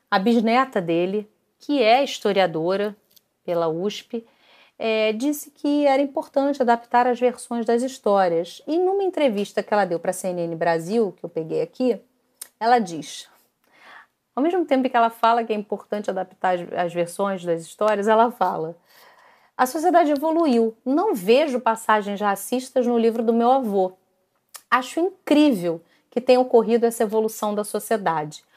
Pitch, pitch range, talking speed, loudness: 230 Hz, 195-255 Hz, 150 wpm, -22 LUFS